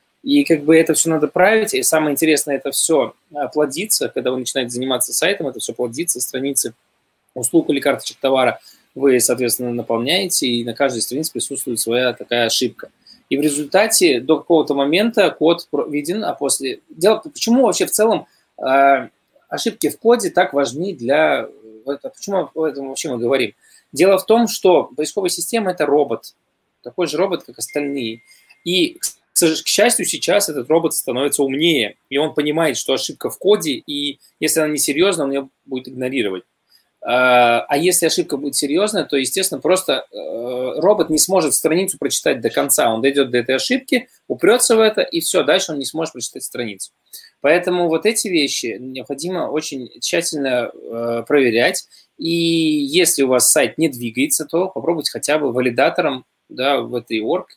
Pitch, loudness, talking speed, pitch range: 150 Hz, -17 LUFS, 165 wpm, 130-180 Hz